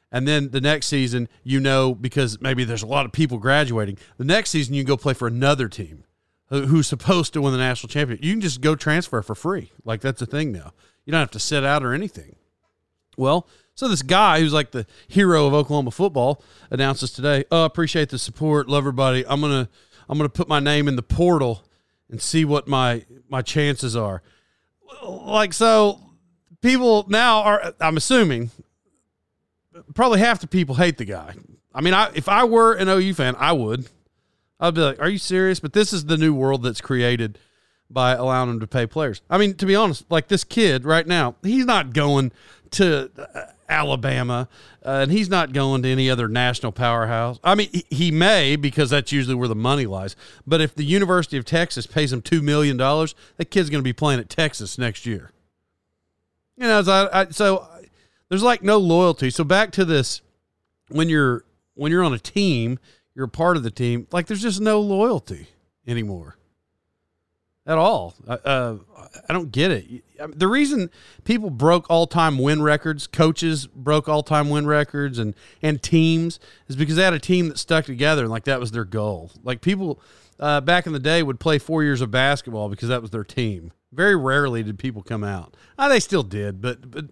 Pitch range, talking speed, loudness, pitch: 120-170 Hz, 200 wpm, -20 LUFS, 145 Hz